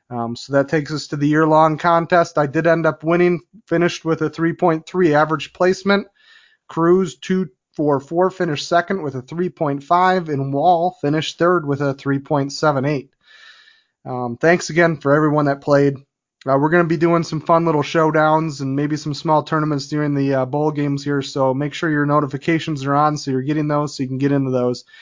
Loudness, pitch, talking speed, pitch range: -18 LUFS, 155 Hz, 195 wpm, 140-170 Hz